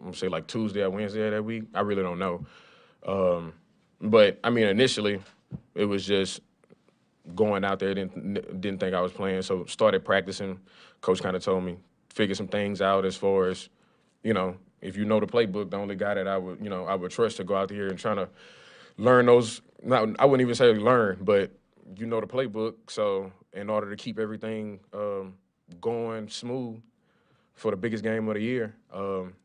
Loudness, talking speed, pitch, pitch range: -27 LUFS, 205 wpm, 100 Hz, 95-110 Hz